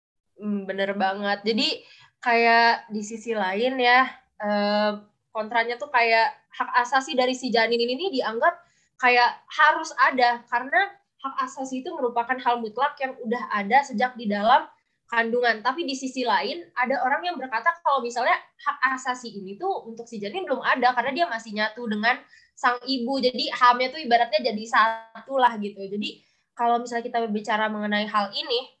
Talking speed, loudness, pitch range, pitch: 160 wpm, -24 LUFS, 225-265 Hz, 245 Hz